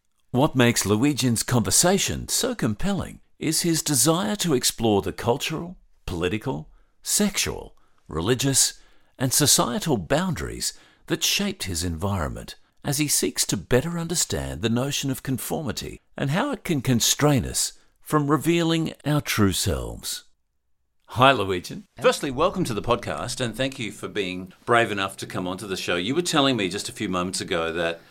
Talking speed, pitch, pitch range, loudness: 155 wpm, 125 Hz, 100-155 Hz, -23 LUFS